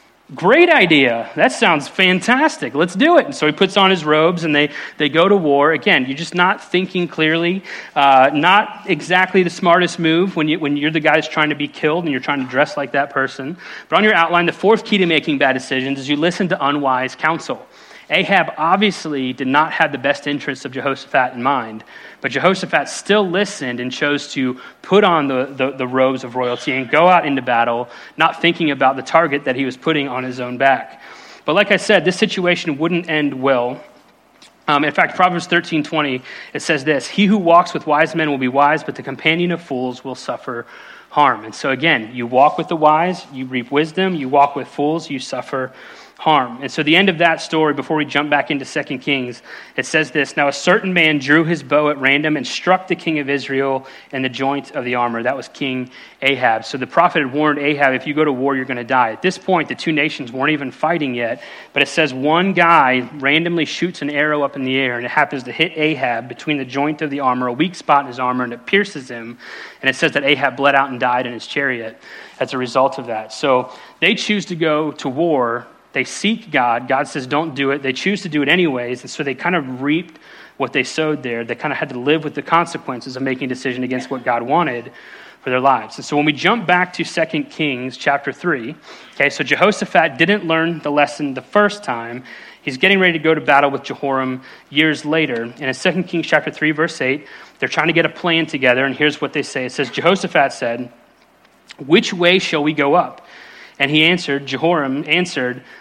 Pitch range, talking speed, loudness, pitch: 135-165 Hz, 230 wpm, -16 LUFS, 145 Hz